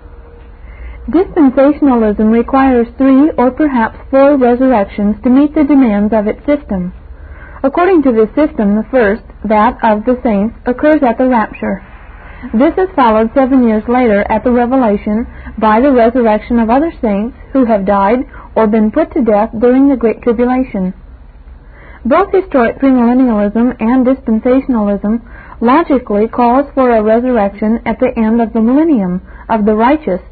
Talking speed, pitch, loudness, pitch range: 145 wpm, 235 Hz, -11 LUFS, 215-265 Hz